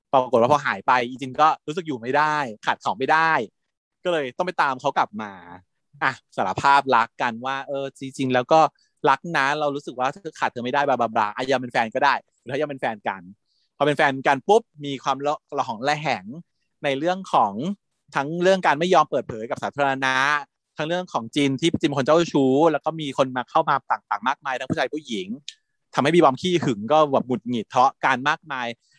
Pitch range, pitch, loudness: 130-155 Hz, 140 Hz, -22 LUFS